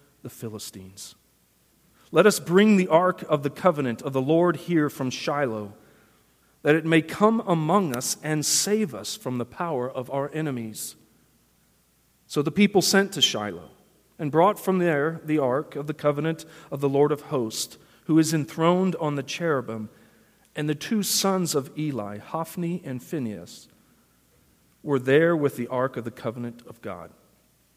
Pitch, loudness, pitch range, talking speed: 150 Hz, -24 LUFS, 125-170 Hz, 165 wpm